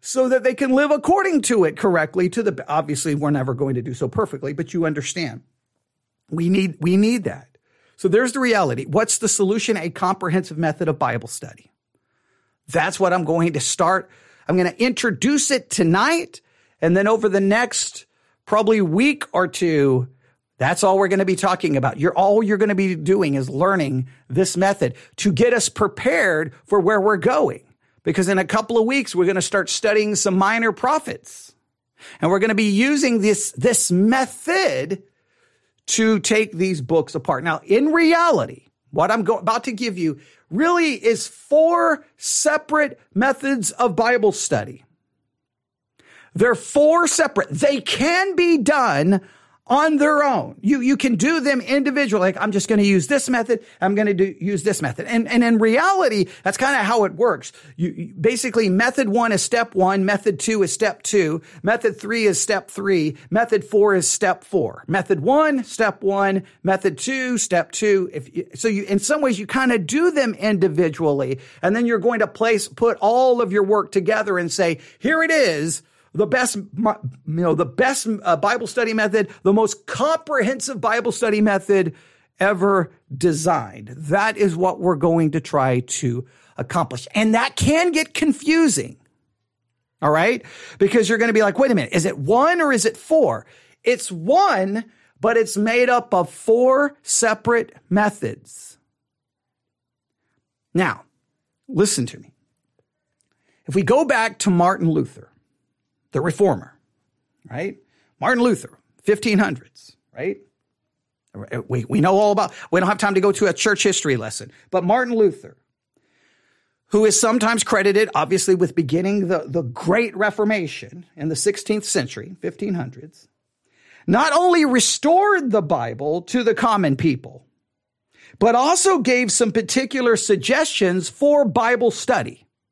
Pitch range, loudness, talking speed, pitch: 165-235 Hz, -19 LUFS, 165 wpm, 205 Hz